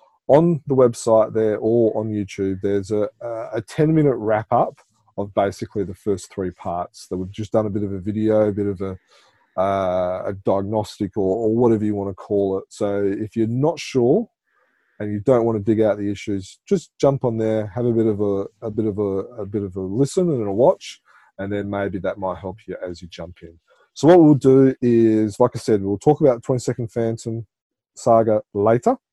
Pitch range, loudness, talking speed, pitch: 100-120 Hz, -20 LUFS, 220 wpm, 110 Hz